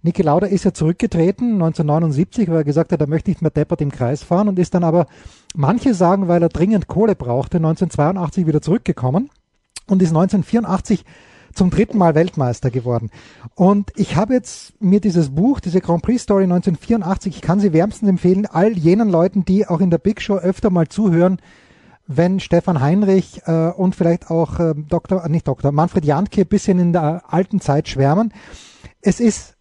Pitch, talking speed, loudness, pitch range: 180 Hz, 180 wpm, -17 LUFS, 165-195 Hz